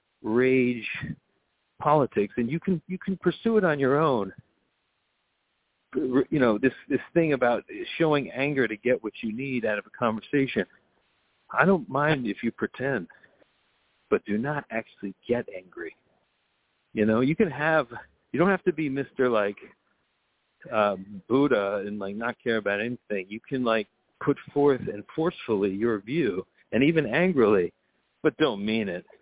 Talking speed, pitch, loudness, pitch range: 160 wpm, 125 Hz, -26 LUFS, 110-150 Hz